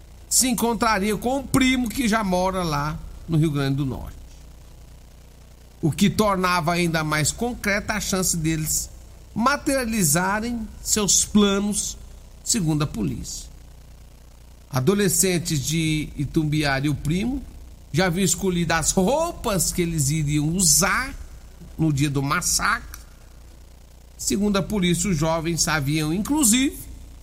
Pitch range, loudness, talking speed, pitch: 135-200 Hz, -21 LUFS, 120 wpm, 165 Hz